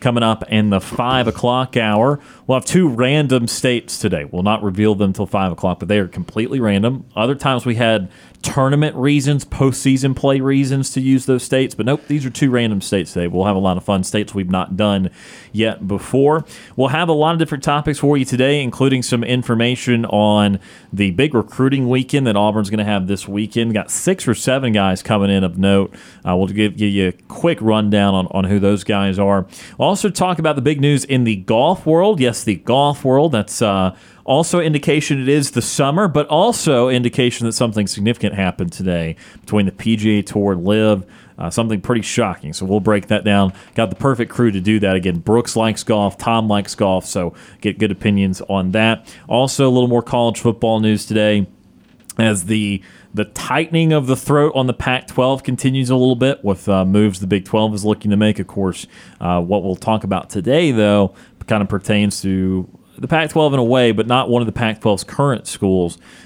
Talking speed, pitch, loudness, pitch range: 210 wpm, 110 Hz, -17 LUFS, 100-130 Hz